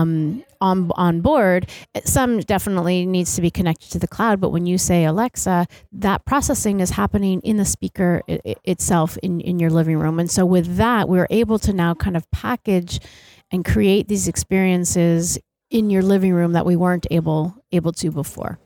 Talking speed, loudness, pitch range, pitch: 185 wpm, -19 LUFS, 170-195 Hz, 180 Hz